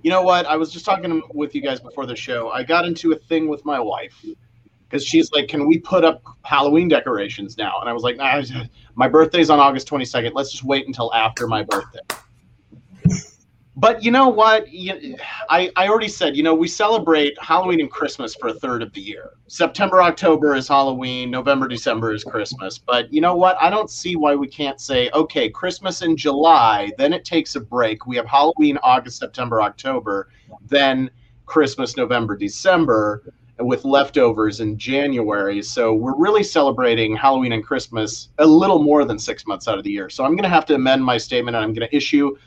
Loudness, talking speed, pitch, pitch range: -18 LUFS, 200 wpm, 140 Hz, 120-165 Hz